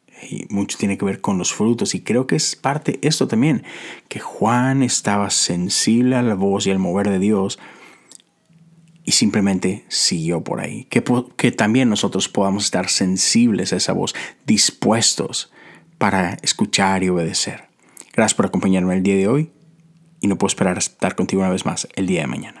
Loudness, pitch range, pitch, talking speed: -18 LUFS, 95-135 Hz, 100 Hz, 185 wpm